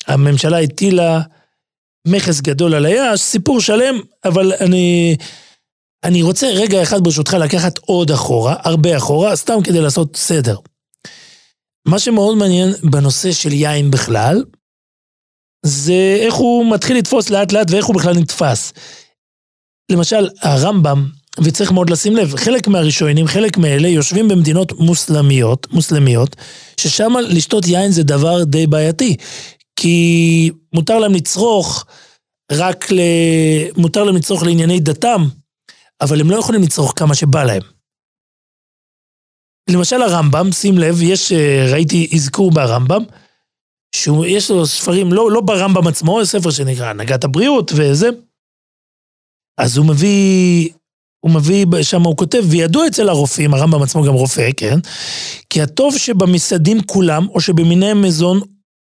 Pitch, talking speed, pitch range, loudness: 170 Hz, 125 wpm, 150-195 Hz, -13 LUFS